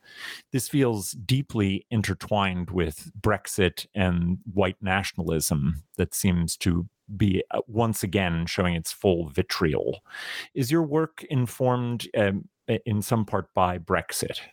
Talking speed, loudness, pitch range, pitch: 120 wpm, -26 LUFS, 90-115 Hz, 100 Hz